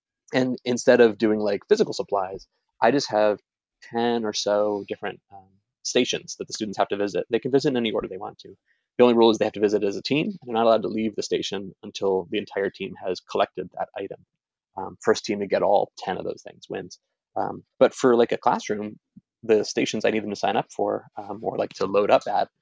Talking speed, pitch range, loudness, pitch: 240 wpm, 105-120 Hz, -24 LUFS, 110 Hz